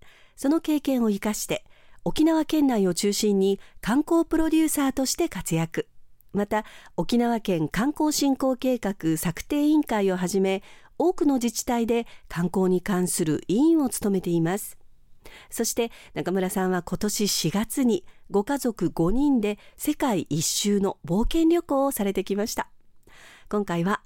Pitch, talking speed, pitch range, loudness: 210 Hz, 275 characters per minute, 185-275 Hz, -25 LUFS